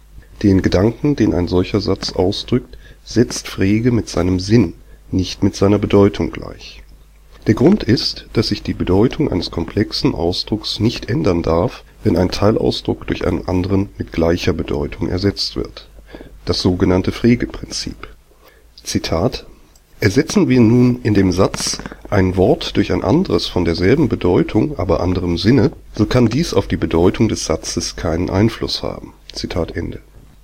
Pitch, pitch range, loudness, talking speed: 95 Hz, 90-110 Hz, -17 LUFS, 150 wpm